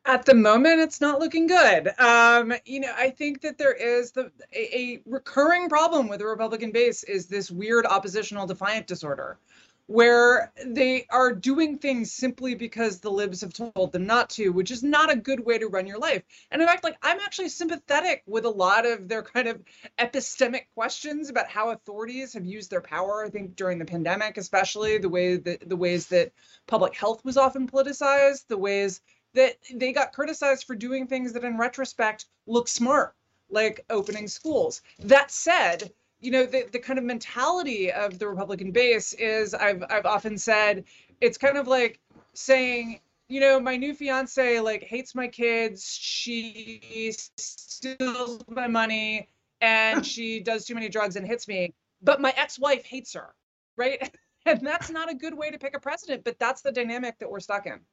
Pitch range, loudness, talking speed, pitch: 215-270 Hz, -24 LUFS, 185 wpm, 240 Hz